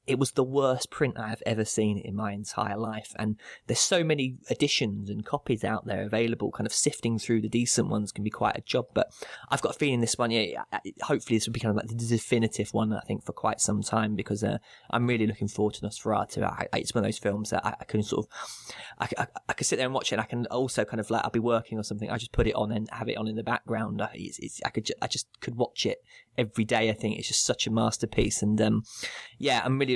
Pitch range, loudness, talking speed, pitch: 105-120 Hz, -29 LUFS, 265 wpm, 110 Hz